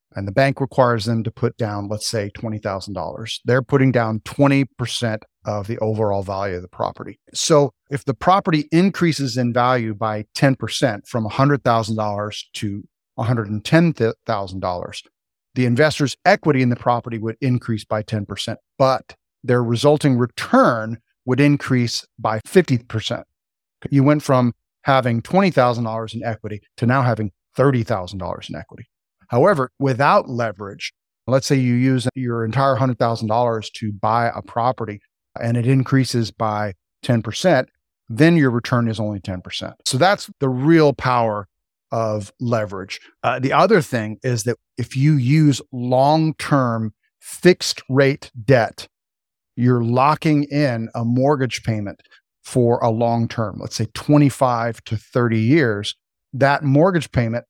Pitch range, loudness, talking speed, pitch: 110-135 Hz, -19 LUFS, 135 wpm, 120 Hz